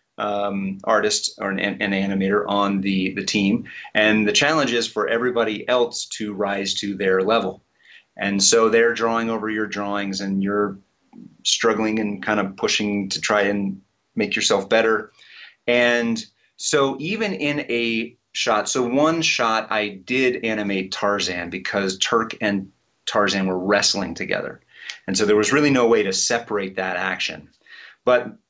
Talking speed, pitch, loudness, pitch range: 155 wpm, 105 Hz, -21 LUFS, 100-115 Hz